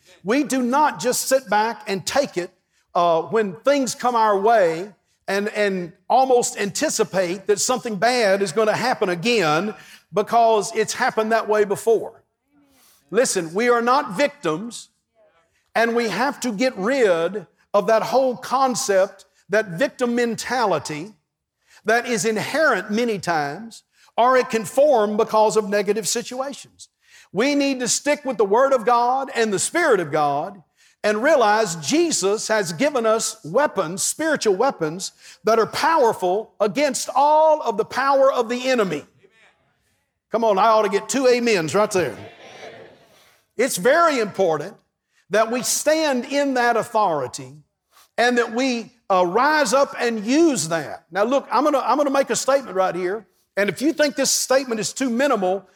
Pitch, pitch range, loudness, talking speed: 225 Hz, 200-260 Hz, -20 LUFS, 155 wpm